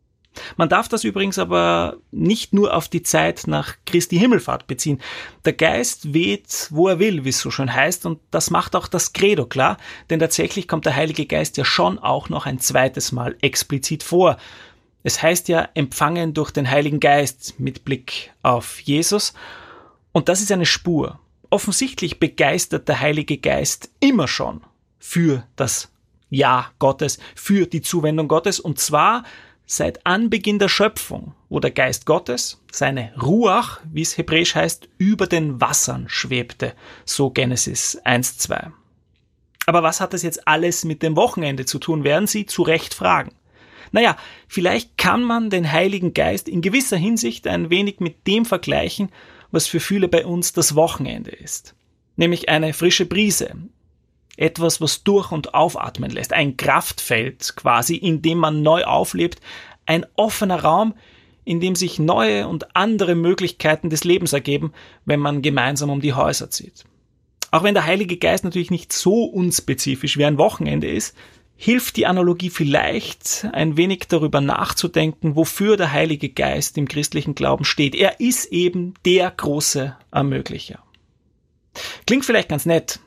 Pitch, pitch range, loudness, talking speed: 165 Hz, 145-185 Hz, -19 LUFS, 155 wpm